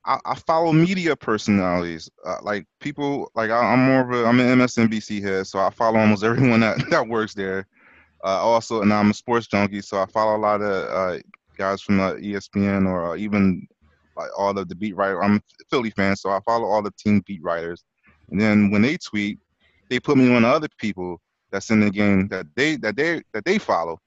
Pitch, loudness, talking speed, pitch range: 105 Hz, -21 LUFS, 220 wpm, 100-115 Hz